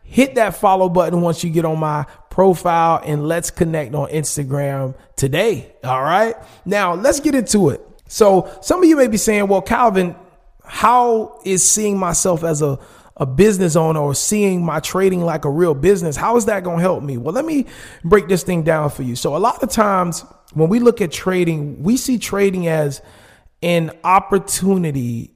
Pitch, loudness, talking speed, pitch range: 180 Hz, -16 LUFS, 190 wpm, 155-205 Hz